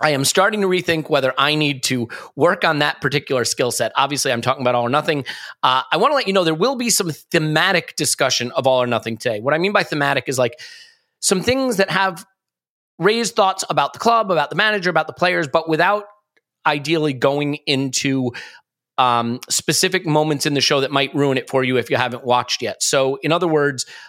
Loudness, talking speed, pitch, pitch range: -18 LUFS, 220 wpm, 155 Hz, 135-190 Hz